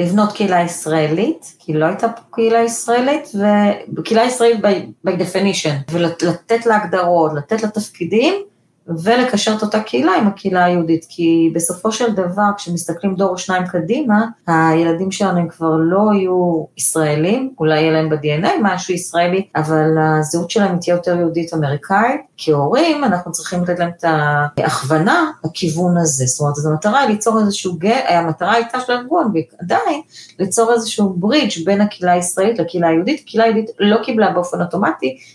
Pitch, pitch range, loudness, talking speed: 180 Hz, 165-215 Hz, -16 LUFS, 145 wpm